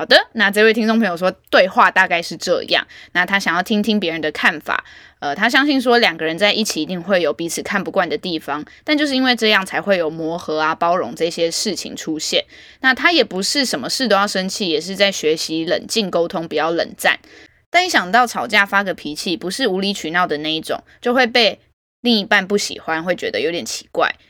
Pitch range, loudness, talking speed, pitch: 170-240 Hz, -17 LUFS, 330 characters per minute, 195 Hz